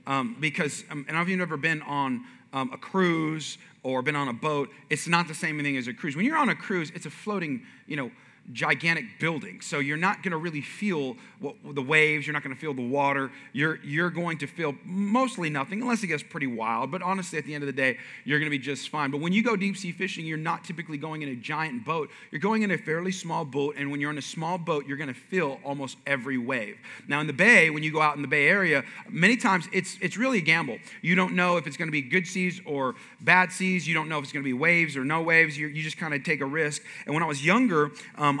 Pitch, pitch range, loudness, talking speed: 155 Hz, 145-180 Hz, -26 LUFS, 275 wpm